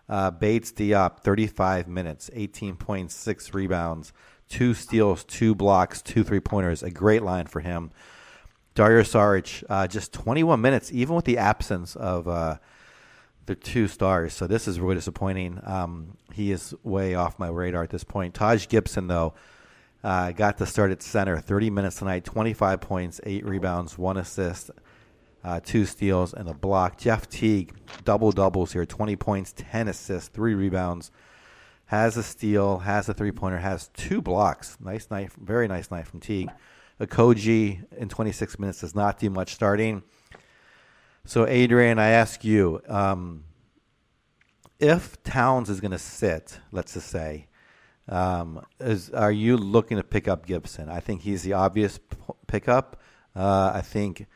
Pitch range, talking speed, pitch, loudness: 90-110 Hz, 160 wpm, 100 Hz, -25 LUFS